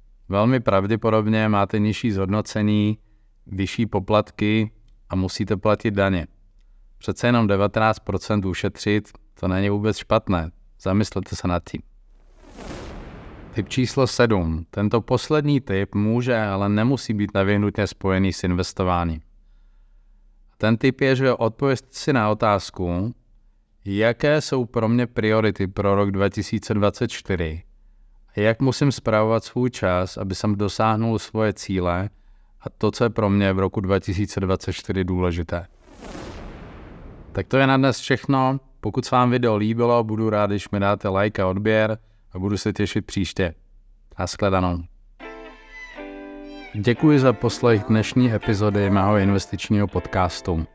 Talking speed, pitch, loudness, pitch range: 125 wpm, 105 Hz, -22 LUFS, 95-115 Hz